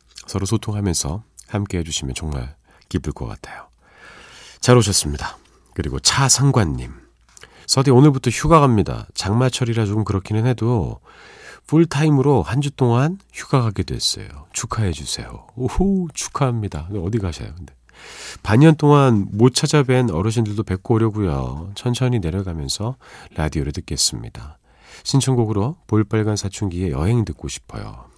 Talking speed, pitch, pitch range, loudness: 315 characters per minute, 110 Hz, 90-125 Hz, -19 LUFS